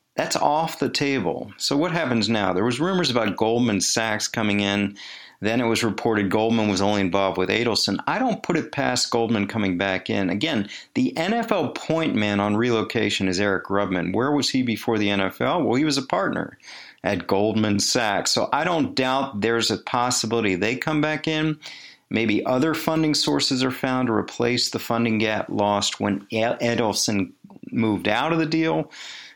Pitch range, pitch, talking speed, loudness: 100-130 Hz, 115 Hz, 180 wpm, -22 LUFS